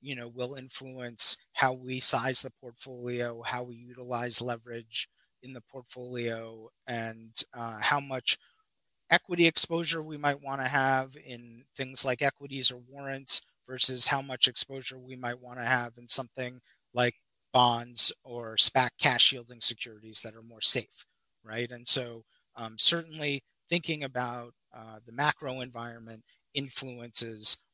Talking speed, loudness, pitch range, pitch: 145 wpm, -25 LUFS, 120-135 Hz, 125 Hz